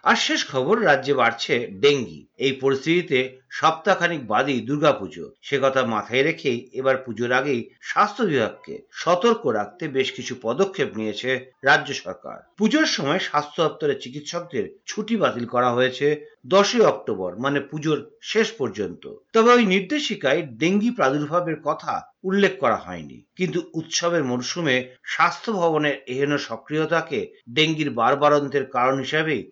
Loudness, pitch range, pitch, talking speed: -22 LUFS, 130-190 Hz, 155 Hz, 130 wpm